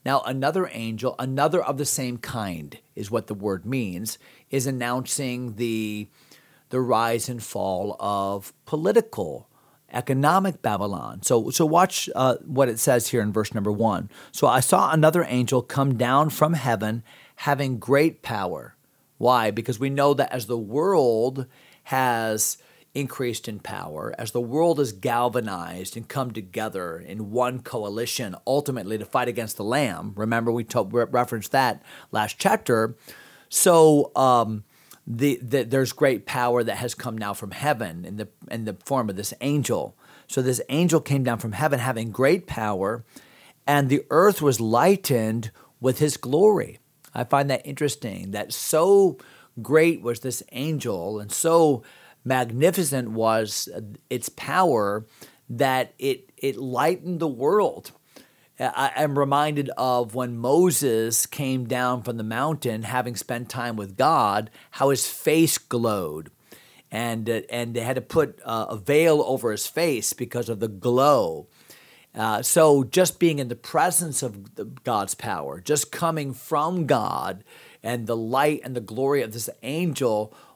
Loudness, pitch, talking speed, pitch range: -23 LUFS, 125 Hz, 150 wpm, 115-145 Hz